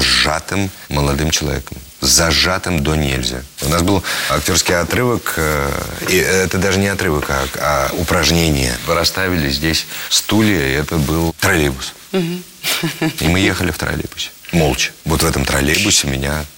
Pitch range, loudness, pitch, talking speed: 70-95 Hz, -15 LUFS, 80 Hz, 140 wpm